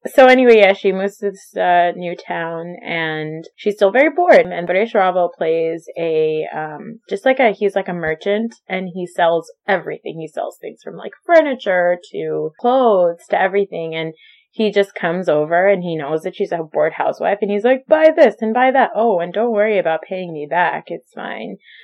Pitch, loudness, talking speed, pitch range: 190 Hz, -16 LUFS, 200 wpm, 170-225 Hz